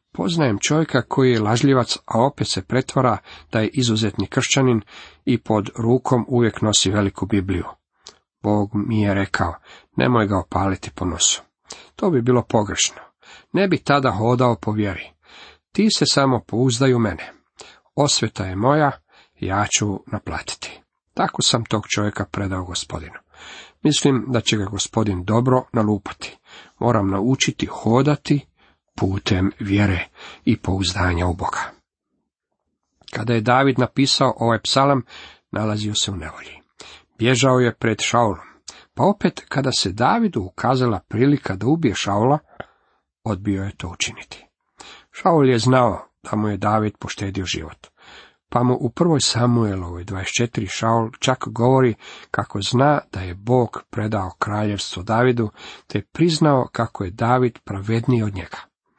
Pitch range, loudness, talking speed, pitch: 100-130 Hz, -20 LUFS, 135 wpm, 115 Hz